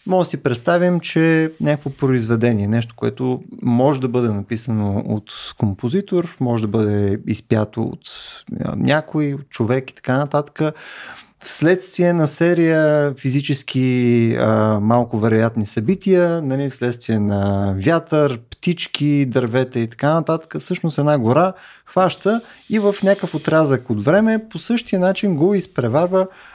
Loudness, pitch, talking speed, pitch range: -18 LUFS, 145 Hz, 130 wpm, 120-175 Hz